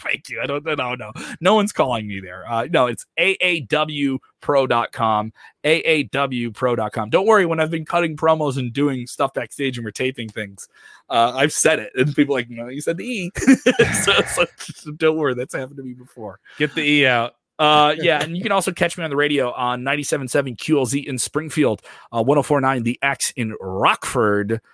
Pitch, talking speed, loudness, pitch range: 140 Hz, 195 wpm, -19 LUFS, 120-155 Hz